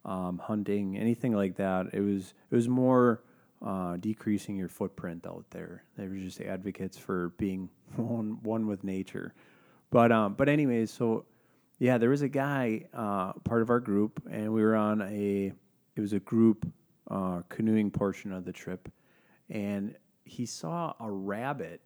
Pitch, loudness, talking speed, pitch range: 105 Hz, -31 LUFS, 165 wpm, 95-115 Hz